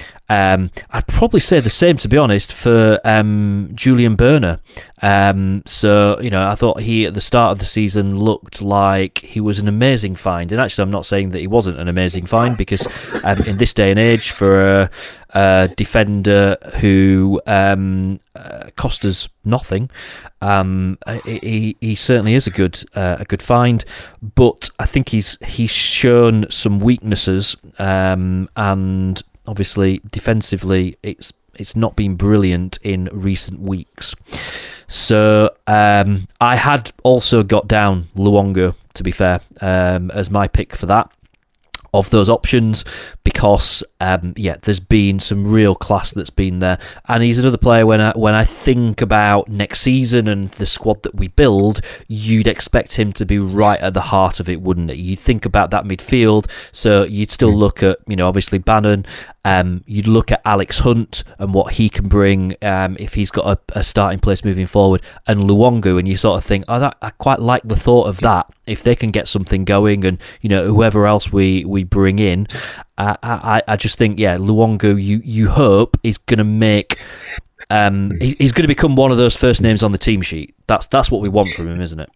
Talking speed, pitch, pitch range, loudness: 185 wpm, 100 Hz, 95-110 Hz, -15 LUFS